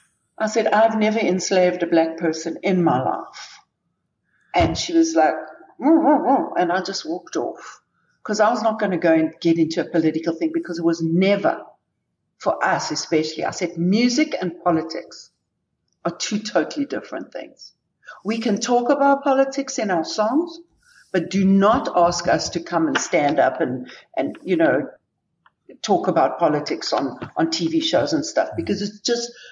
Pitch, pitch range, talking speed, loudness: 205 Hz, 170-270 Hz, 175 wpm, -20 LUFS